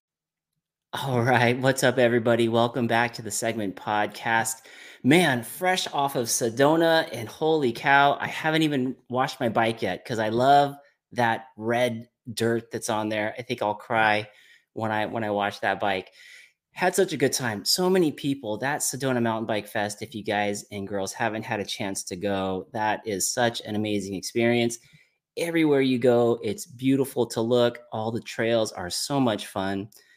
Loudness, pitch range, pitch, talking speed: -25 LUFS, 105-135 Hz, 115 Hz, 180 wpm